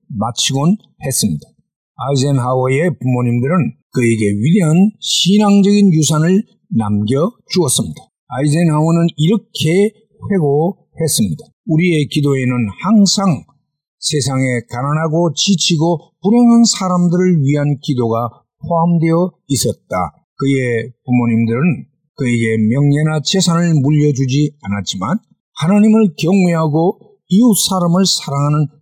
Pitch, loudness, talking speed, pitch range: 160 Hz, -14 LUFS, 275 characters per minute, 135-185 Hz